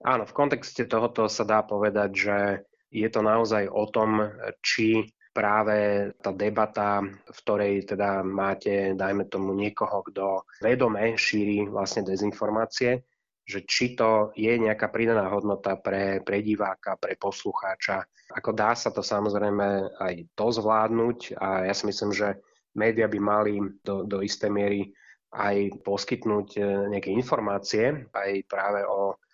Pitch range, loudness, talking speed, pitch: 100-110 Hz, -26 LUFS, 140 wpm, 105 Hz